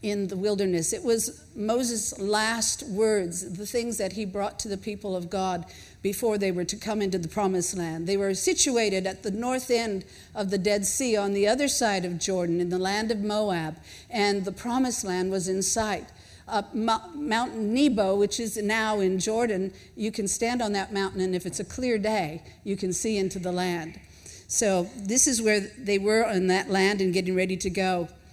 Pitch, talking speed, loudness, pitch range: 200 Hz, 205 wpm, -26 LUFS, 190-220 Hz